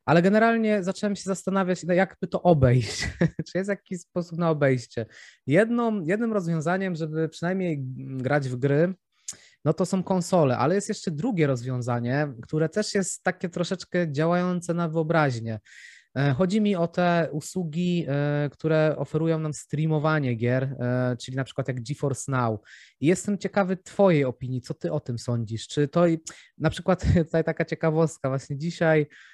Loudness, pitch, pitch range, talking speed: -25 LUFS, 165 Hz, 140-185 Hz, 155 wpm